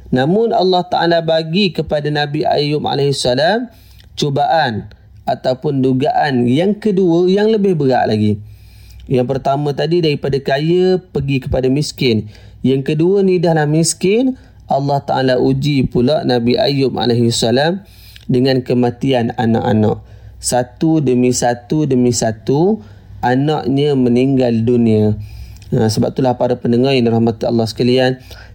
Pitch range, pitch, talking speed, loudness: 120-155 Hz, 130 Hz, 120 wpm, -15 LUFS